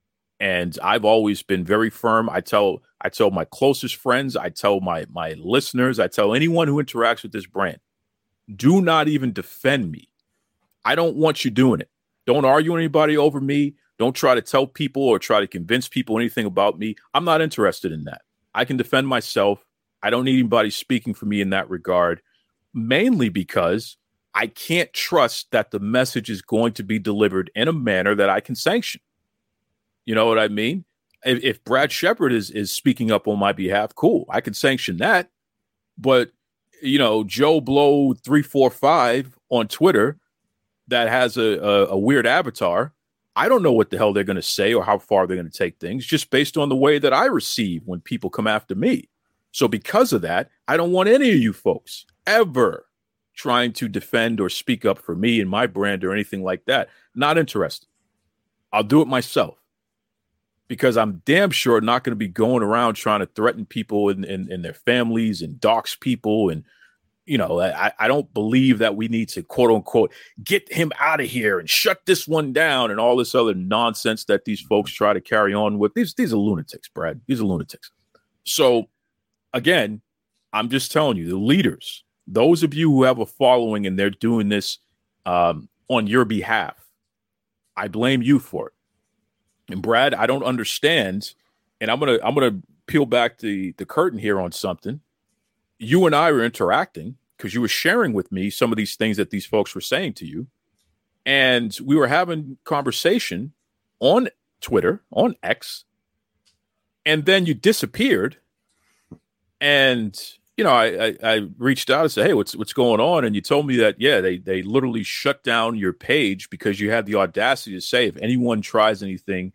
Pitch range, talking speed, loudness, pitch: 105-135 Hz, 190 wpm, -20 LUFS, 115 Hz